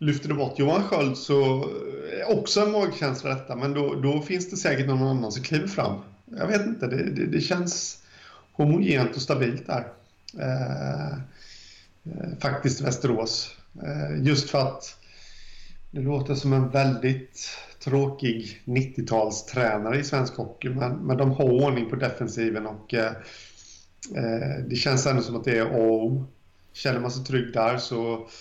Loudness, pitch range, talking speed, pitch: -26 LUFS, 115-140 Hz, 165 wpm, 130 Hz